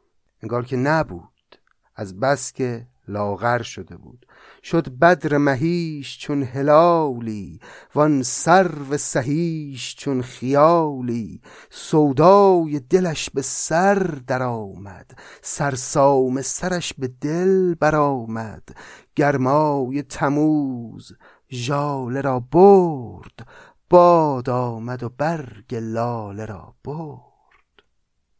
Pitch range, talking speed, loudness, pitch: 120-155 Hz, 95 wpm, -19 LUFS, 140 Hz